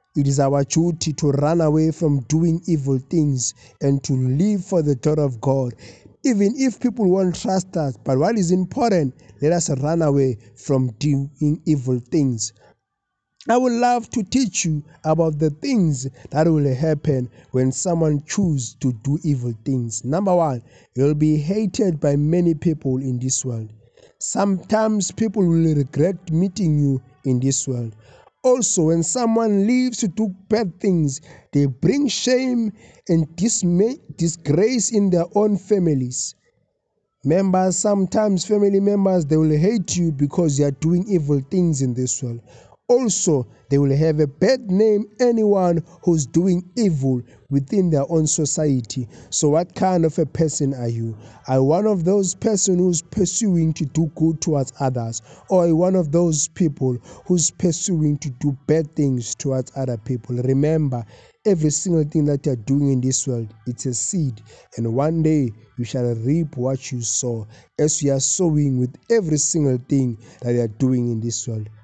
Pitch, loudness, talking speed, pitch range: 155 Hz, -20 LUFS, 165 wpm, 130-180 Hz